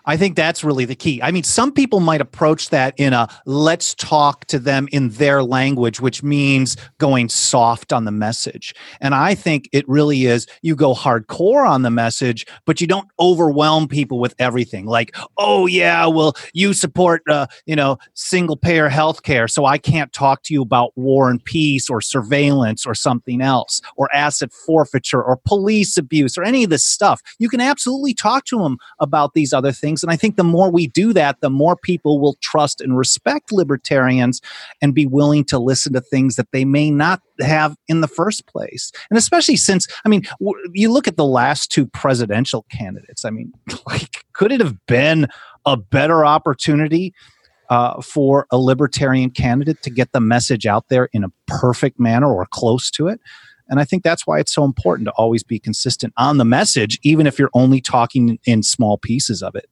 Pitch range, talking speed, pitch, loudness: 125-160 Hz, 200 wpm, 140 Hz, -16 LUFS